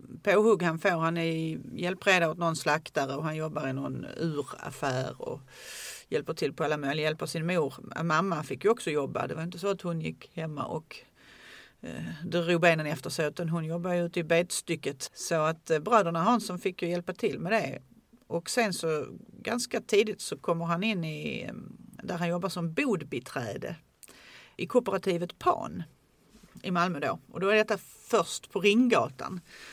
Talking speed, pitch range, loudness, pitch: 180 wpm, 160-205 Hz, -30 LUFS, 175 Hz